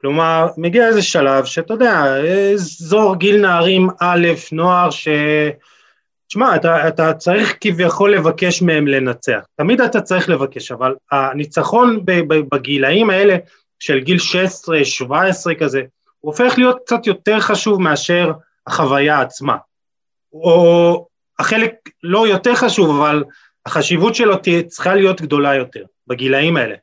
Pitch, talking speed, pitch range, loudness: 170 Hz, 125 wpm, 150-200 Hz, -14 LUFS